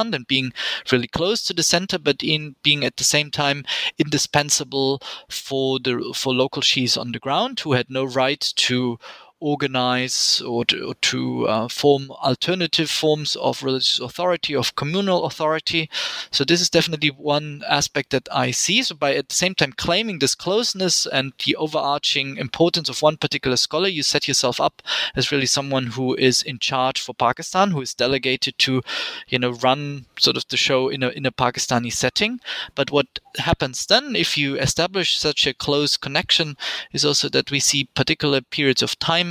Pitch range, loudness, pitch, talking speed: 130-155 Hz, -20 LUFS, 140 Hz, 180 wpm